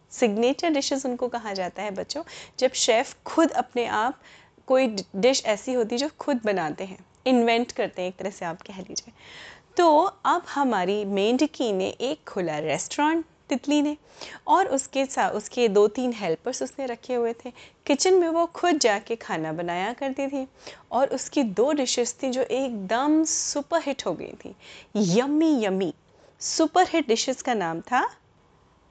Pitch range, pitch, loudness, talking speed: 210-290 Hz, 255 Hz, -25 LUFS, 165 wpm